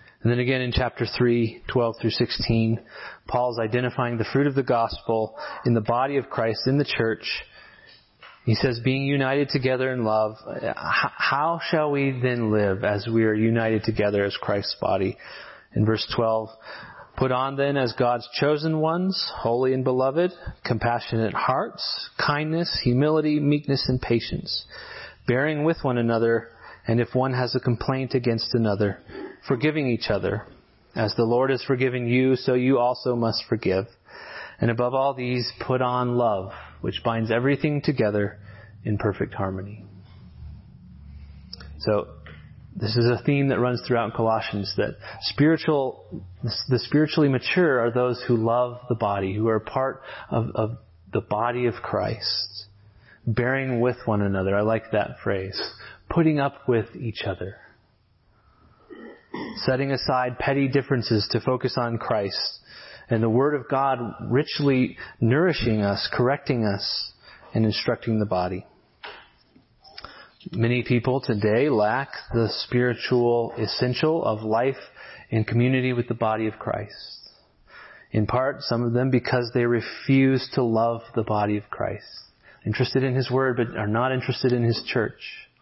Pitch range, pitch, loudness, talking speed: 110-130 Hz, 120 Hz, -24 LUFS, 145 wpm